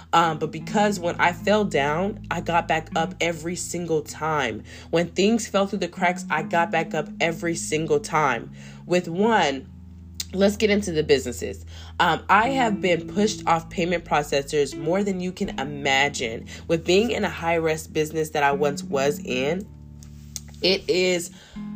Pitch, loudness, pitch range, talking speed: 165 Hz, -23 LUFS, 145-185 Hz, 165 wpm